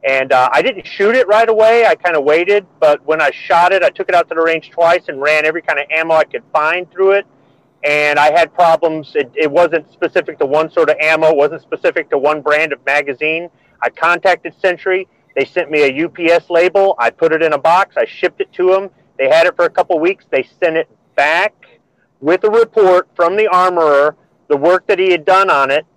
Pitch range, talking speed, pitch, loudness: 155-195 Hz, 235 wpm, 170 Hz, -13 LUFS